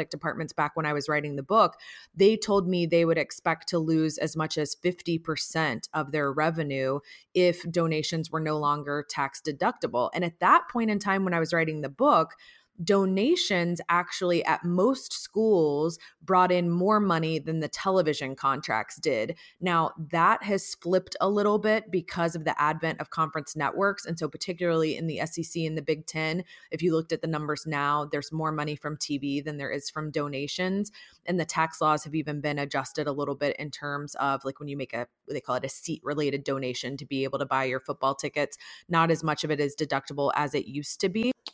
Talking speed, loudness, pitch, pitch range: 205 wpm, -27 LUFS, 155 Hz, 145-175 Hz